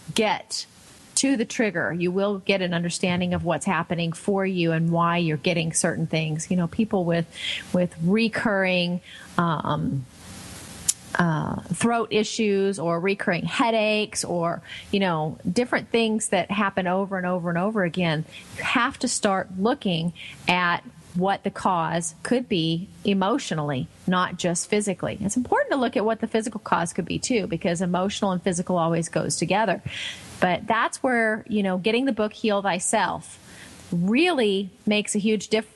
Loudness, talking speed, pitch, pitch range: -24 LUFS, 160 wpm, 190 Hz, 175-215 Hz